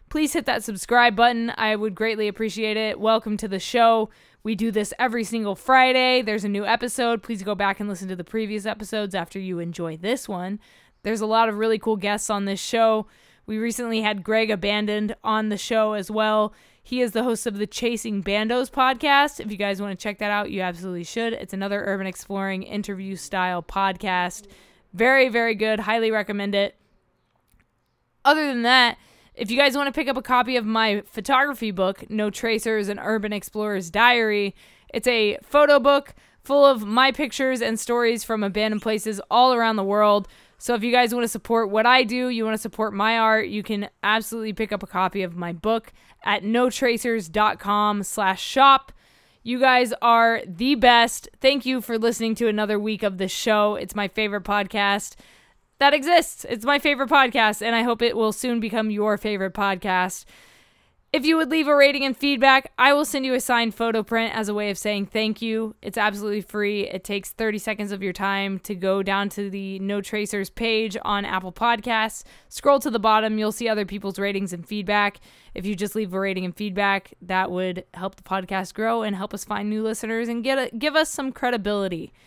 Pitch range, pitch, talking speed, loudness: 205-235 Hz, 220 Hz, 200 wpm, -22 LUFS